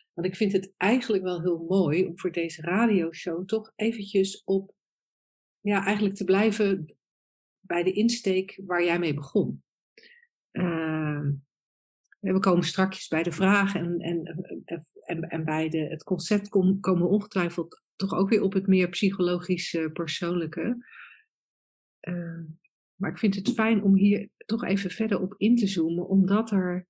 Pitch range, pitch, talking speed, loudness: 170-200 Hz, 185 Hz, 155 wpm, -26 LUFS